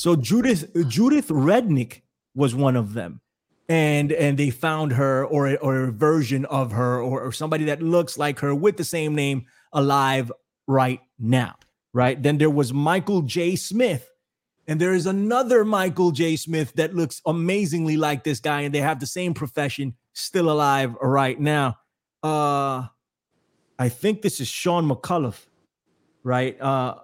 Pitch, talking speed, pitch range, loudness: 145 Hz, 160 wpm, 135-170 Hz, -22 LUFS